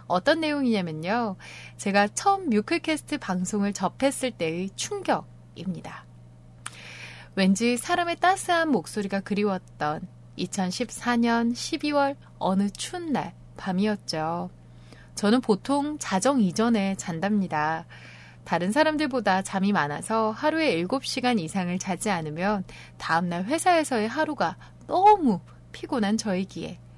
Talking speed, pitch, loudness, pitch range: 255 characters per minute, 205 Hz, -26 LUFS, 170-270 Hz